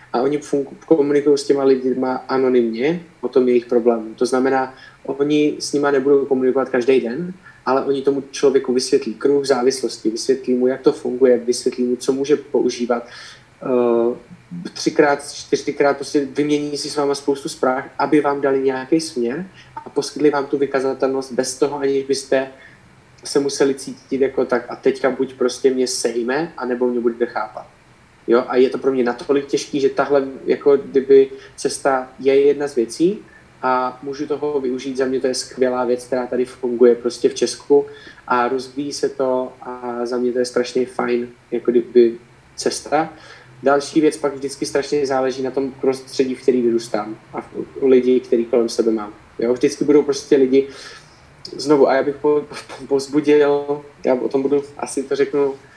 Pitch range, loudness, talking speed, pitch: 125-145 Hz, -19 LUFS, 170 wpm, 135 Hz